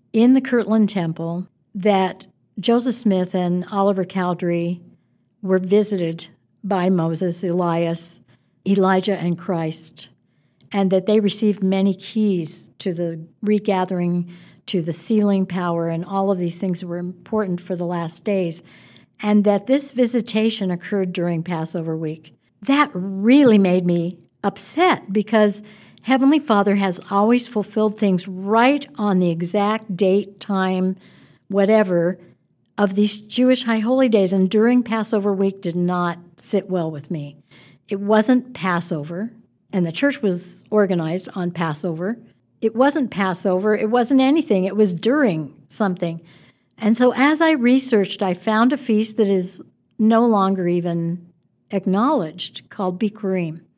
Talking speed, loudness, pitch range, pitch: 135 wpm, -20 LUFS, 175-215 Hz, 195 Hz